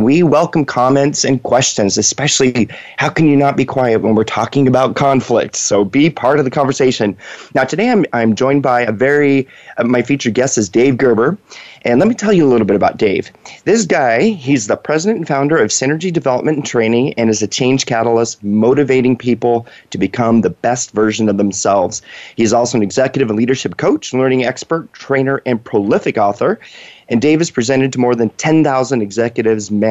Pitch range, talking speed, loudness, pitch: 115-140 Hz, 195 wpm, -14 LUFS, 130 Hz